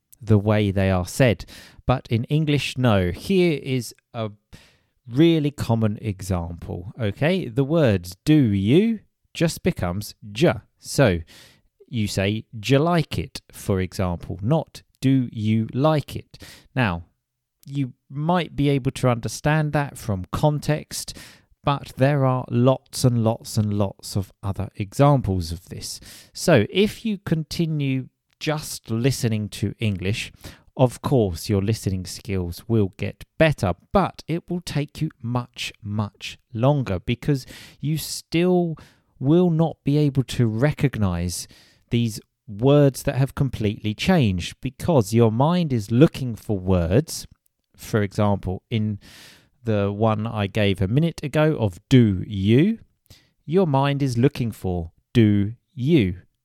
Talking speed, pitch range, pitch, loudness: 135 wpm, 105-145 Hz, 120 Hz, -22 LUFS